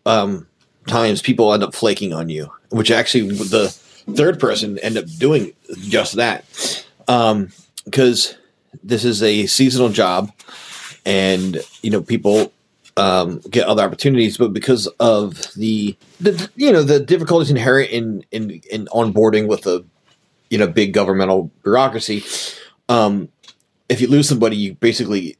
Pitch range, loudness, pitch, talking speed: 105-125 Hz, -17 LUFS, 110 Hz, 145 wpm